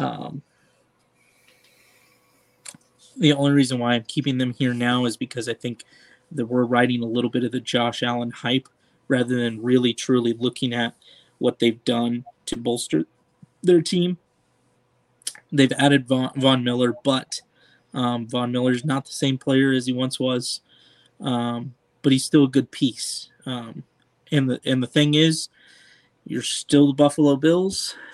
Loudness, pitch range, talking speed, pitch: -22 LUFS, 120-140 Hz, 160 wpm, 125 Hz